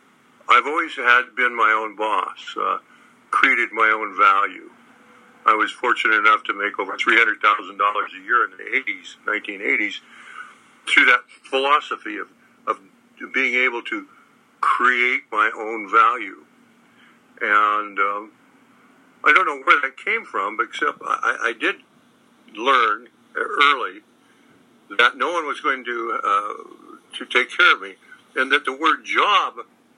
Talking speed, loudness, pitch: 140 wpm, -19 LUFS, 390 Hz